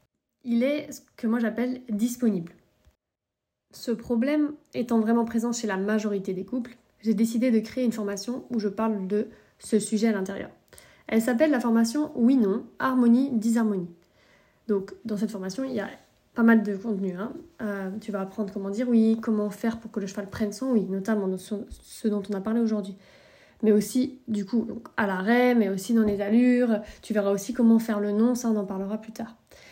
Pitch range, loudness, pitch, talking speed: 205-240 Hz, -26 LUFS, 225 Hz, 195 wpm